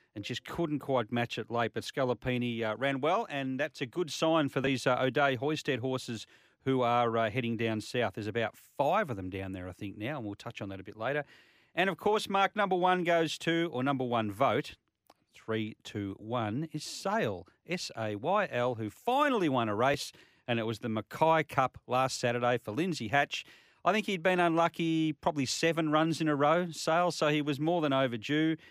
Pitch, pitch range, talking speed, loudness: 135 Hz, 115-160 Hz, 205 wpm, -31 LUFS